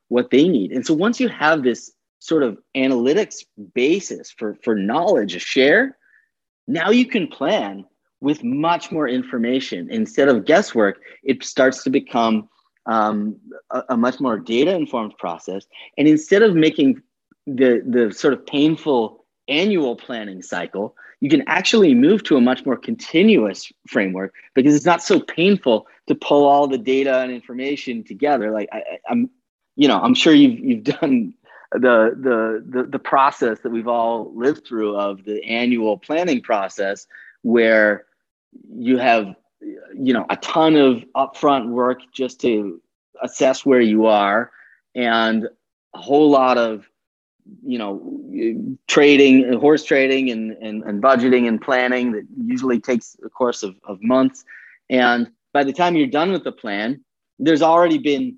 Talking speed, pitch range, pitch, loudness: 155 wpm, 120-170 Hz, 130 Hz, -18 LUFS